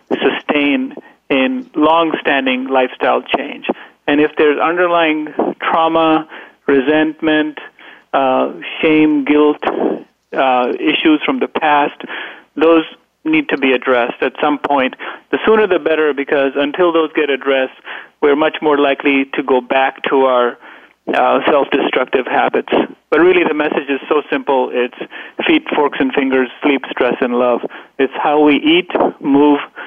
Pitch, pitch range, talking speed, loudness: 150 Hz, 135-165 Hz, 140 wpm, -14 LUFS